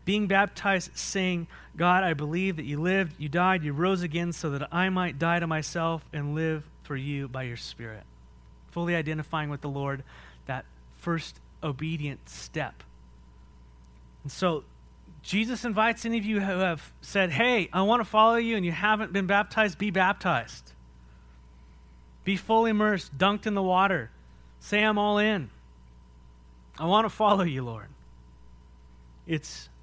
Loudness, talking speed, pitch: -27 LUFS, 155 wpm, 160 Hz